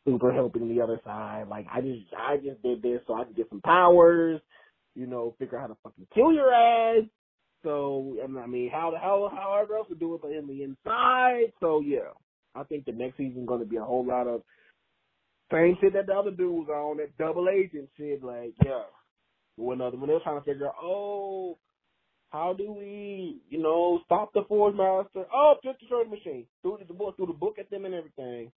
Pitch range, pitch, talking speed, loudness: 125-200 Hz, 160 Hz, 220 wpm, -27 LUFS